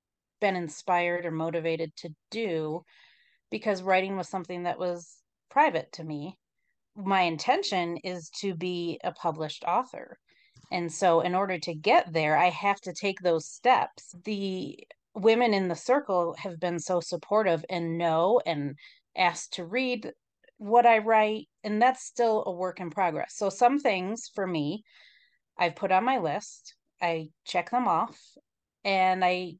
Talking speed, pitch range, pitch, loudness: 155 wpm, 170-215 Hz, 185 Hz, -28 LUFS